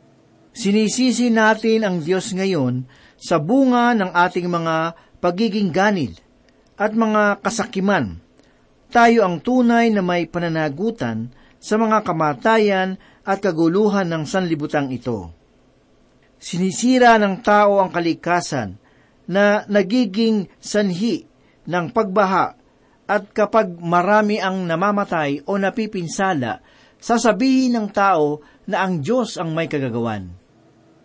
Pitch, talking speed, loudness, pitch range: 195 Hz, 105 wpm, -19 LUFS, 165-215 Hz